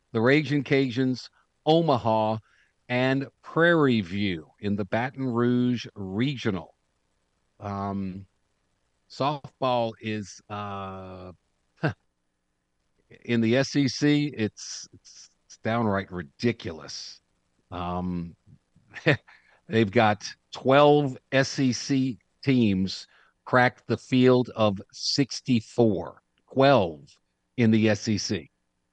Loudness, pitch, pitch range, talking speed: -25 LUFS, 115 Hz, 95-130 Hz, 80 wpm